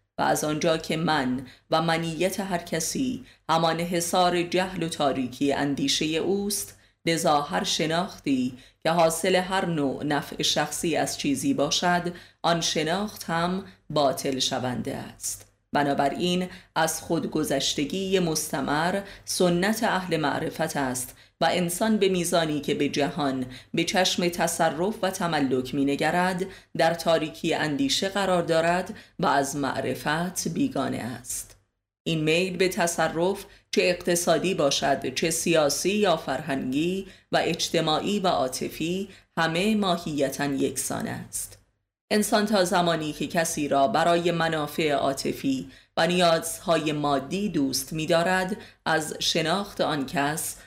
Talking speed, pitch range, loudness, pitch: 120 wpm, 140-185 Hz, -25 LUFS, 165 Hz